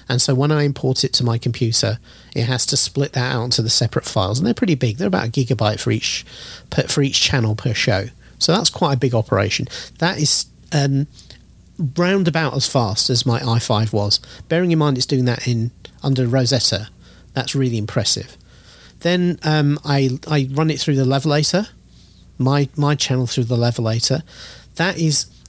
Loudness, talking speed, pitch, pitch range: -18 LUFS, 190 wpm, 130 Hz, 115-145 Hz